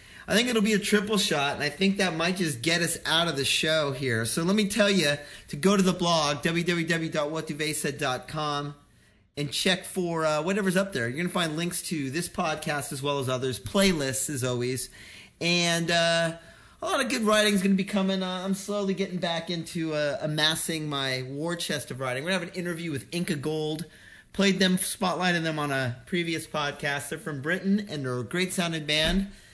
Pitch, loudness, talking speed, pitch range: 165 Hz, -26 LUFS, 210 wpm, 145-185 Hz